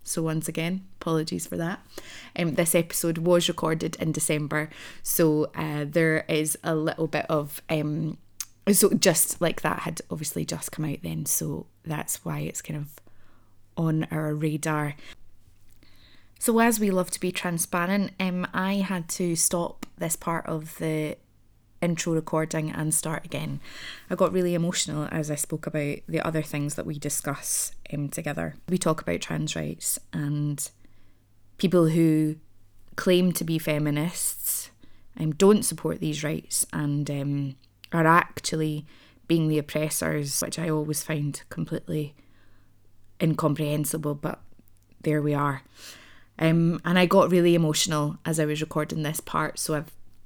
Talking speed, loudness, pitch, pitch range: 155 wpm, -26 LUFS, 155 Hz, 145-165 Hz